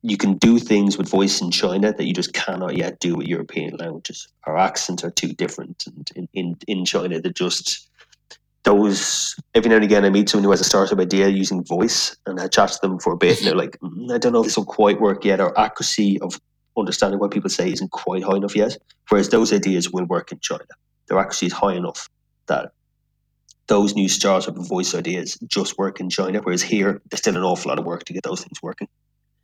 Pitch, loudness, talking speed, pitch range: 100 Hz, -20 LUFS, 230 wpm, 95-110 Hz